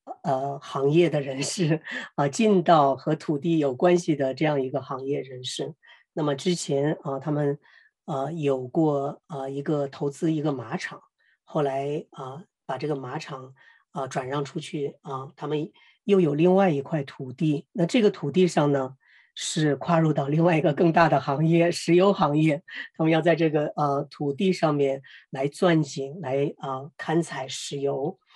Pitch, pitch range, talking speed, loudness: 150 Hz, 140-165 Hz, 240 characters per minute, -25 LUFS